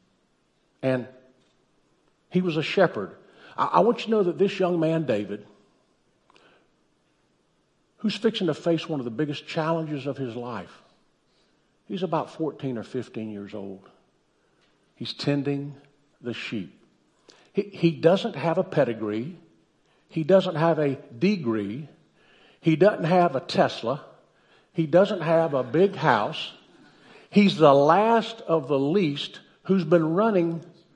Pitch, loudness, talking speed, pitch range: 160 Hz, -24 LUFS, 135 wpm, 135-185 Hz